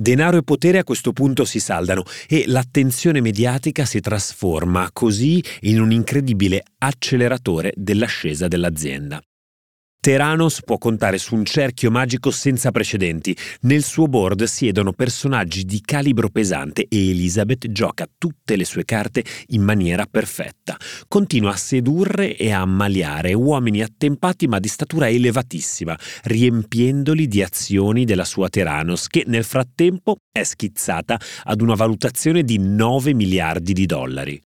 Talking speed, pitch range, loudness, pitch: 135 wpm, 100-135 Hz, -19 LUFS, 115 Hz